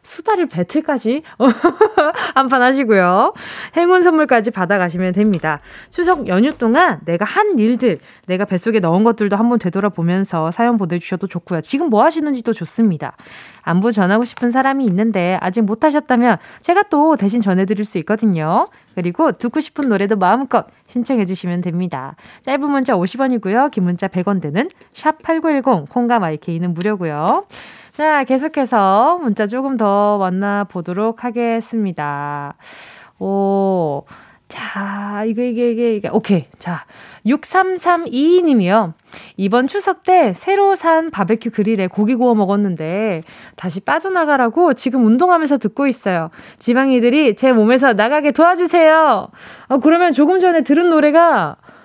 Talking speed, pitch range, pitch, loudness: 310 characters per minute, 195-290 Hz, 230 Hz, -15 LUFS